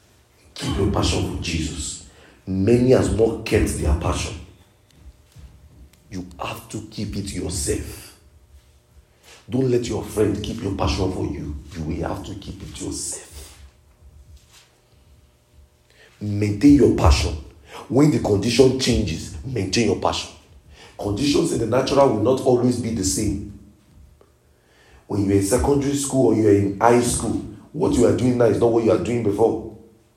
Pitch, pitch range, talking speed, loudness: 100 Hz, 80-110 Hz, 150 wpm, -20 LUFS